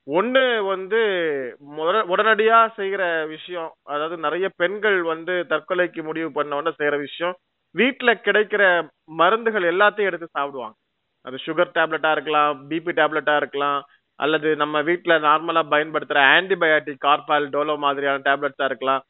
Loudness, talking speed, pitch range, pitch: -20 LUFS, 125 wpm, 150-180 Hz, 160 Hz